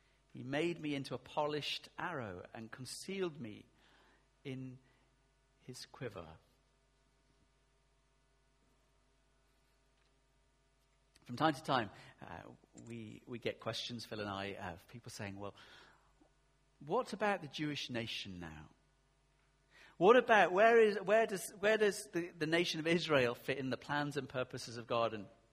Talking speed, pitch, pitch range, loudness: 135 wpm, 135 Hz, 120-145 Hz, -36 LUFS